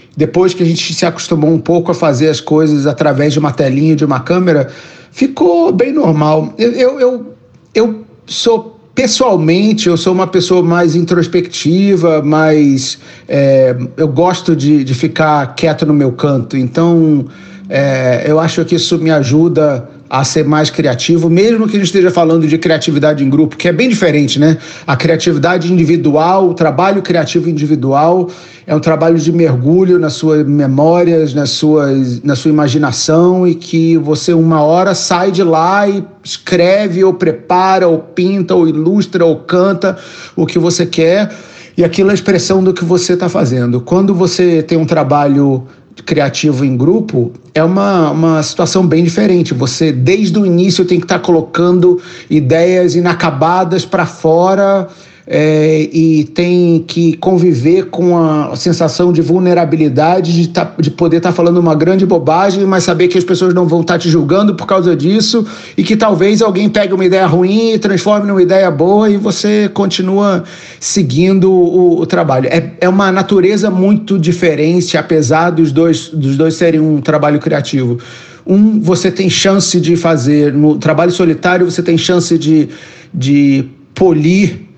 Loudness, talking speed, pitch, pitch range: -10 LUFS, 165 wpm, 170 Hz, 155-185 Hz